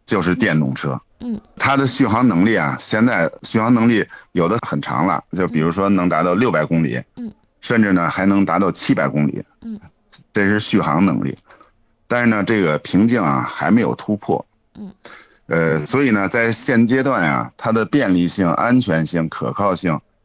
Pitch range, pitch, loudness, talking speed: 85-125 Hz, 100 Hz, -17 LUFS, 260 characters per minute